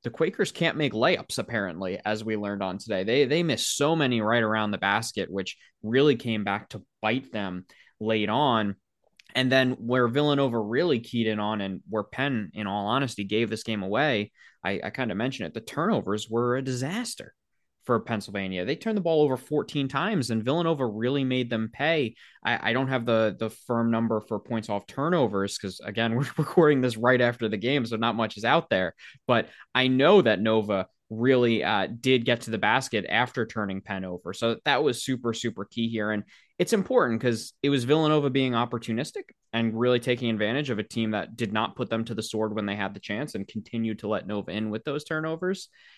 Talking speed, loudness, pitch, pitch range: 210 wpm, -26 LUFS, 115 Hz, 110-135 Hz